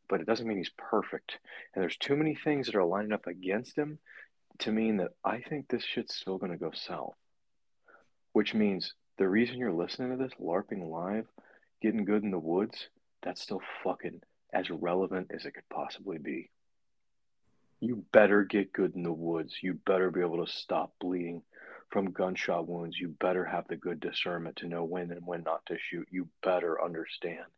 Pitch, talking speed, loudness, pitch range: 100 Hz, 190 wpm, -33 LUFS, 90-115 Hz